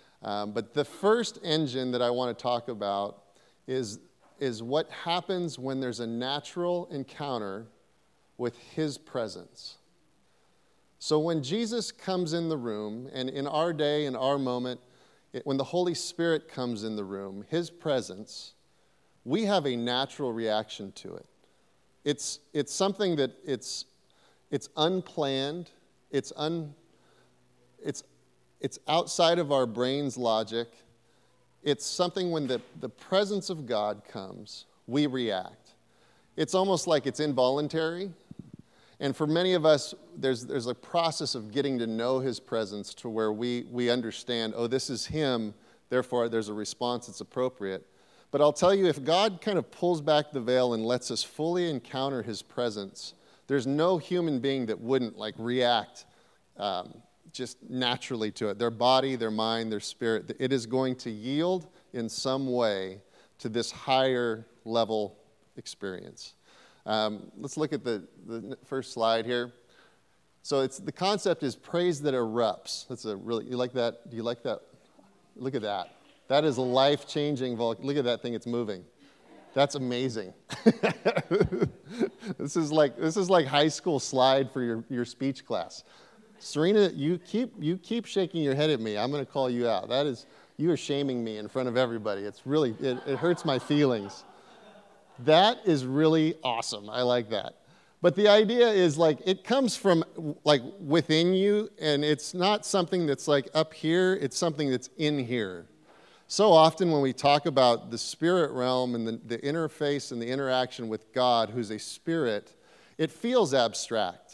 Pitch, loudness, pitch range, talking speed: 135 Hz, -29 LUFS, 120-160 Hz, 165 wpm